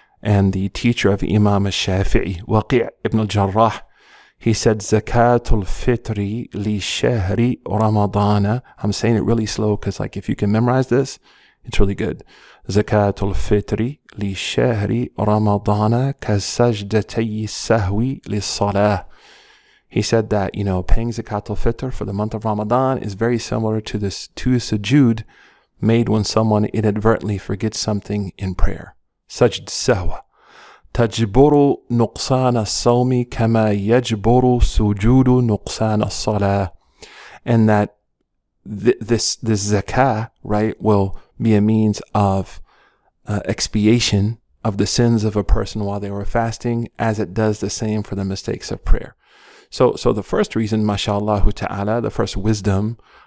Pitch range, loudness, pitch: 100-115 Hz, -19 LUFS, 105 Hz